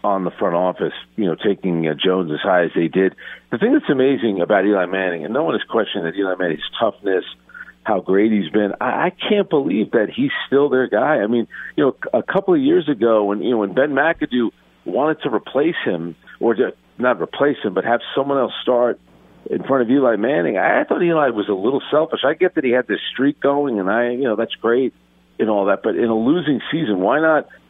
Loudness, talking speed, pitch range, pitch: -18 LUFS, 230 wpm, 95-140 Hz, 115 Hz